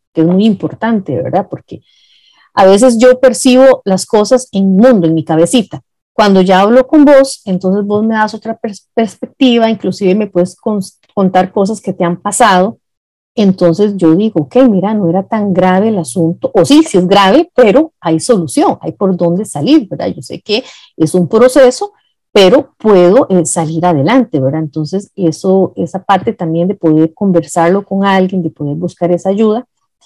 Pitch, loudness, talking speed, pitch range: 195 Hz, -10 LUFS, 180 wpm, 175-225 Hz